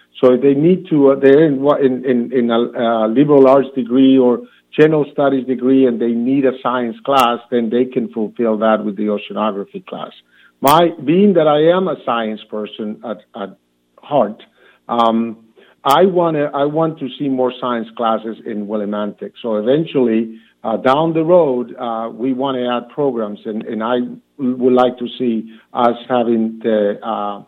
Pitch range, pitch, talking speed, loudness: 115-135 Hz, 125 Hz, 175 wpm, -15 LUFS